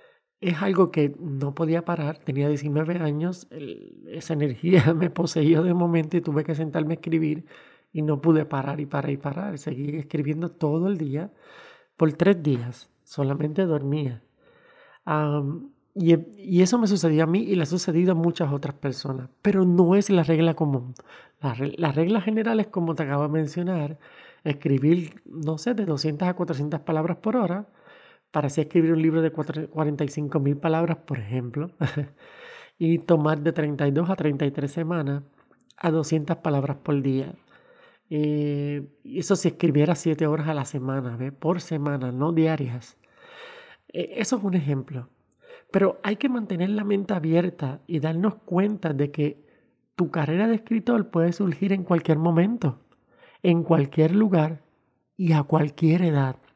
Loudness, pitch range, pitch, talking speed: -24 LUFS, 150-180 Hz, 160 Hz, 160 wpm